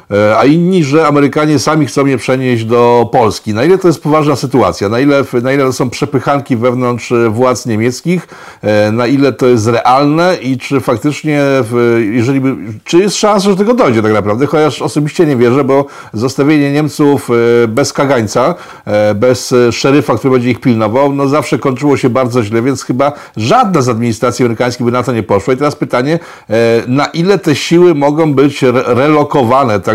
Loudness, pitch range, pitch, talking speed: -10 LUFS, 120-150 Hz, 135 Hz, 170 wpm